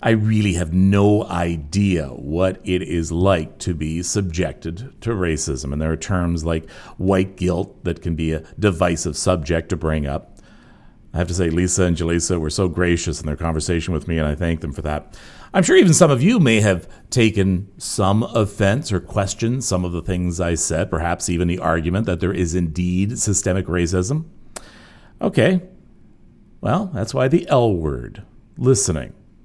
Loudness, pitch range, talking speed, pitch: -20 LUFS, 80-100 Hz, 180 wpm, 90 Hz